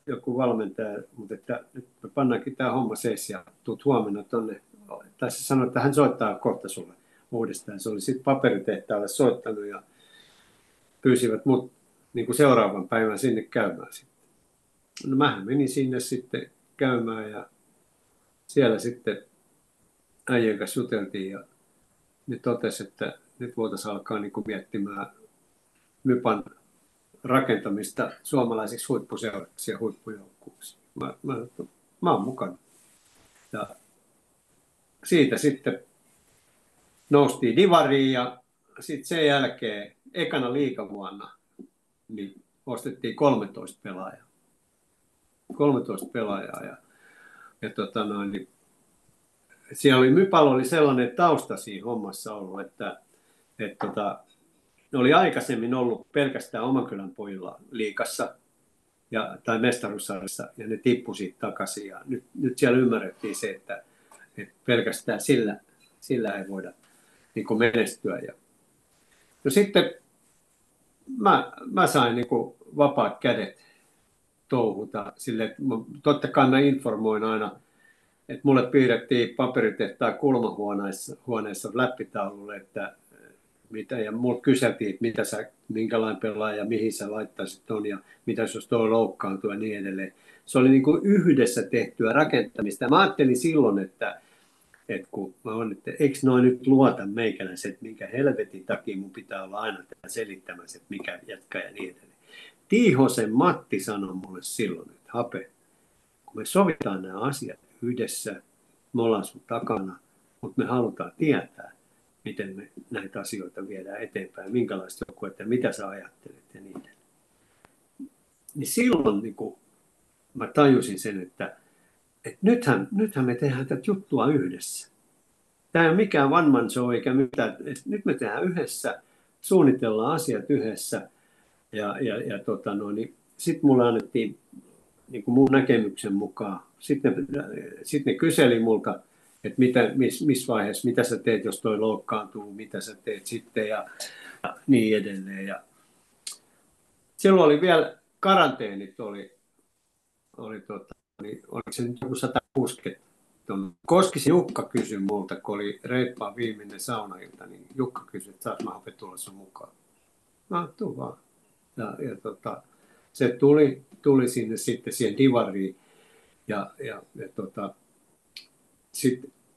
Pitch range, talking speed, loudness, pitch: 105-140 Hz, 130 wpm, -25 LUFS, 120 Hz